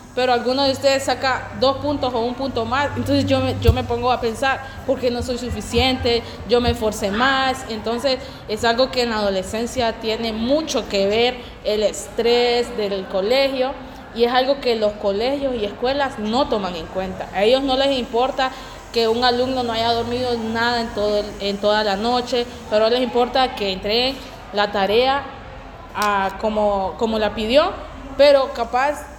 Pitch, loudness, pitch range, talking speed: 240 Hz, -20 LUFS, 215-260 Hz, 175 wpm